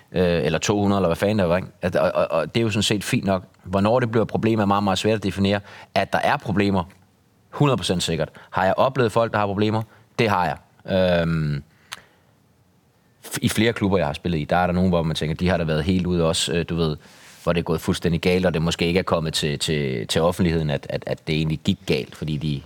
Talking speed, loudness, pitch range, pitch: 250 wpm, -22 LUFS, 85-105 Hz, 95 Hz